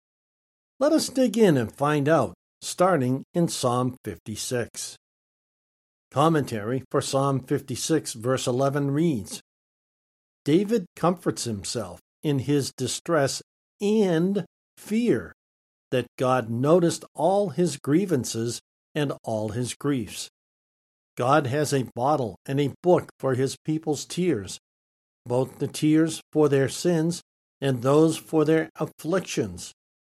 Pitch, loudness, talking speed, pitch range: 140 Hz, -25 LUFS, 115 wpm, 125-160 Hz